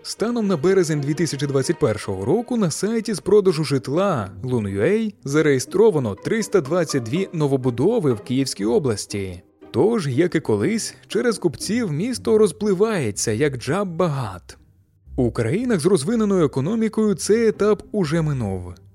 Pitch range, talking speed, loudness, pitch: 125-205 Hz, 115 wpm, -21 LUFS, 160 Hz